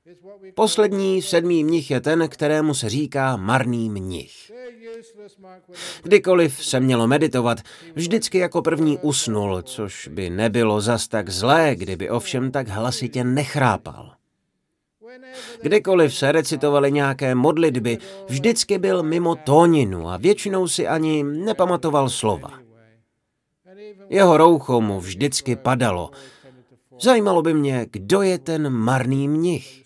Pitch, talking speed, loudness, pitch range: 145 Hz, 115 wpm, -20 LUFS, 125-175 Hz